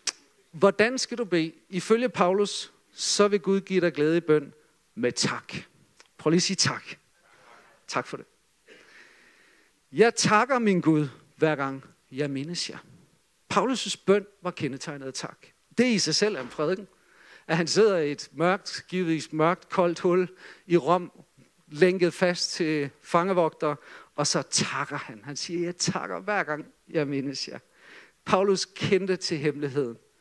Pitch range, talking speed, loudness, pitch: 155-195 Hz, 155 wpm, -26 LUFS, 175 Hz